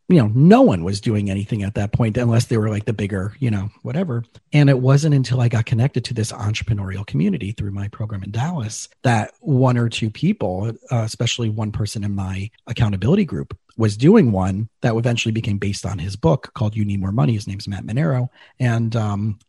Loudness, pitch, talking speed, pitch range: -20 LUFS, 115 Hz, 210 wpm, 105-125 Hz